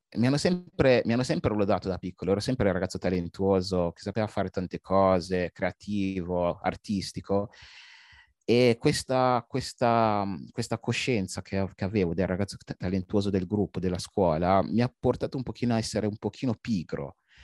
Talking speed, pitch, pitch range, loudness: 155 wpm, 100 Hz, 95-120 Hz, -28 LUFS